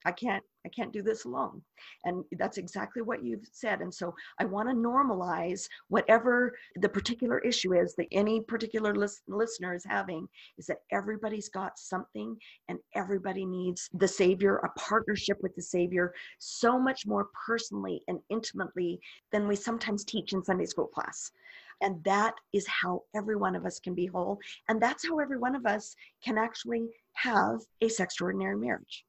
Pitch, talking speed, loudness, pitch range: 205 Hz, 175 wpm, -32 LUFS, 185-230 Hz